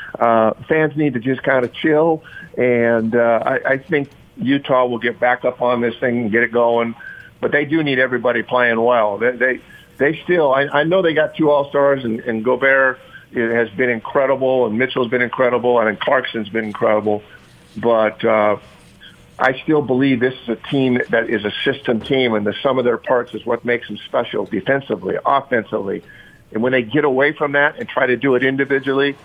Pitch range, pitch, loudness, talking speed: 115-140 Hz, 125 Hz, -17 LUFS, 200 wpm